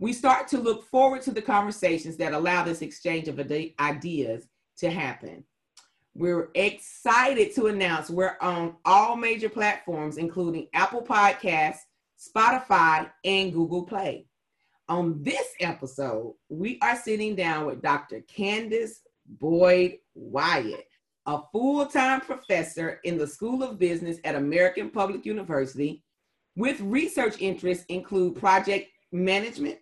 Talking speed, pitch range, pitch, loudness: 125 wpm, 165-220 Hz, 185 Hz, -26 LUFS